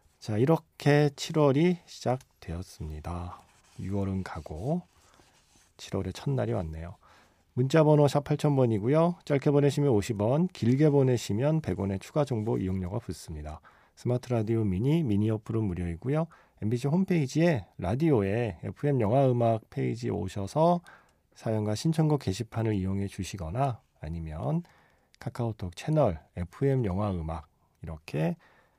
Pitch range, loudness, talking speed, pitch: 95-145 Hz, -28 LUFS, 290 characters per minute, 115 Hz